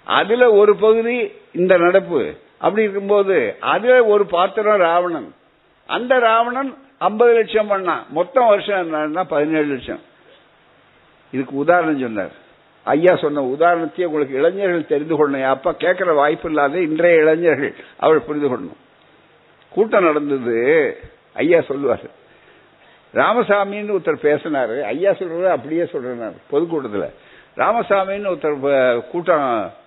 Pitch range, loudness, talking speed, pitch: 155-220 Hz, -17 LUFS, 105 wpm, 180 Hz